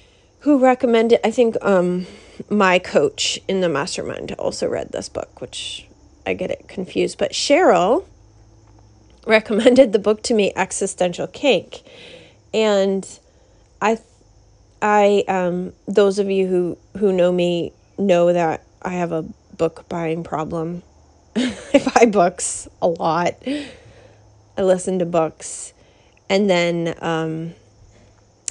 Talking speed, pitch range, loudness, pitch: 125 wpm, 160-210 Hz, -19 LUFS, 185 Hz